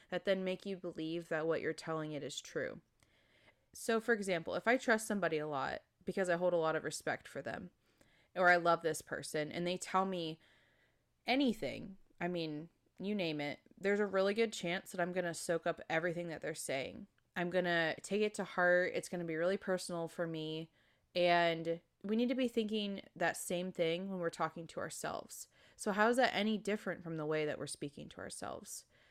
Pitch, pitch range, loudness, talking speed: 175 Hz, 160-200 Hz, -37 LUFS, 210 wpm